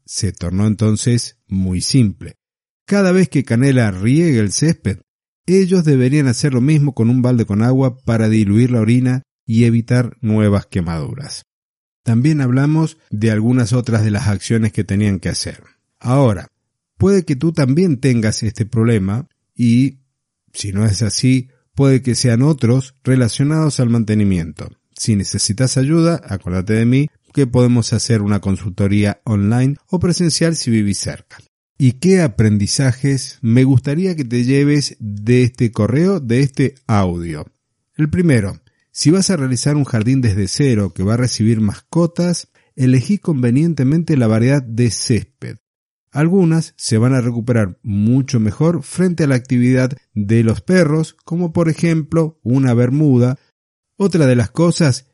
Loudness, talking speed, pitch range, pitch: -15 LUFS, 150 wpm, 110-145 Hz, 125 Hz